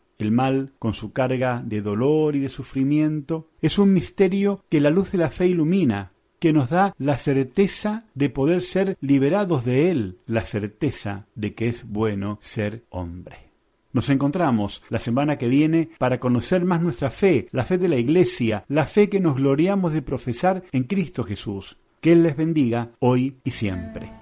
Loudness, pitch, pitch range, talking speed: -22 LUFS, 140 Hz, 115-170 Hz, 180 wpm